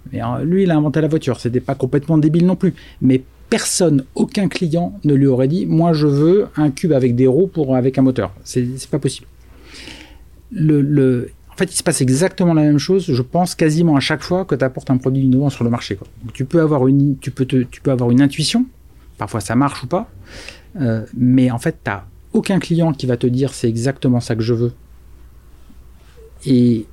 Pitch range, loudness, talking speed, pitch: 125-160 Hz, -16 LUFS, 225 wpm, 135 Hz